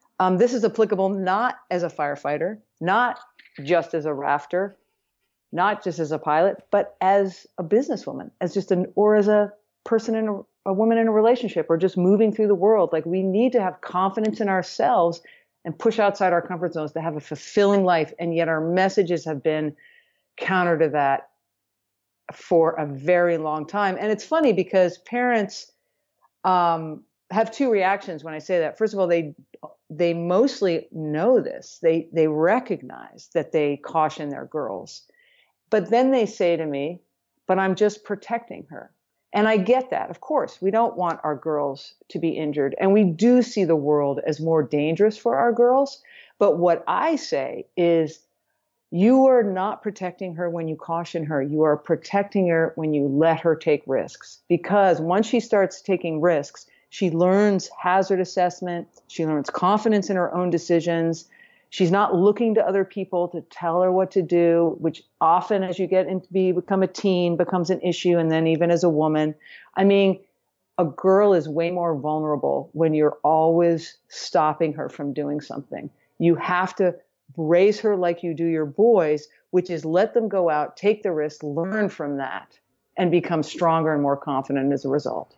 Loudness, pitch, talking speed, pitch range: -22 LUFS, 180 Hz, 185 wpm, 160-200 Hz